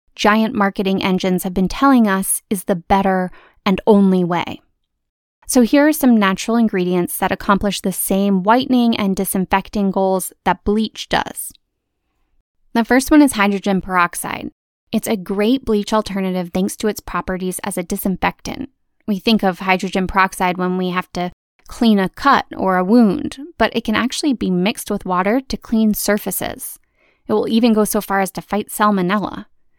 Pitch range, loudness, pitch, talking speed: 190-225 Hz, -17 LUFS, 200 Hz, 170 wpm